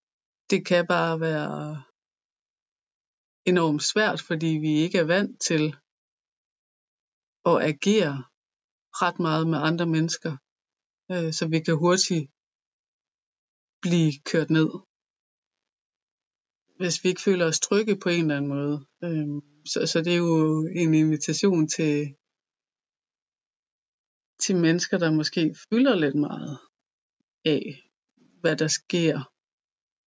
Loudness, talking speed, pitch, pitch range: -24 LUFS, 115 wpm, 160 Hz, 155-175 Hz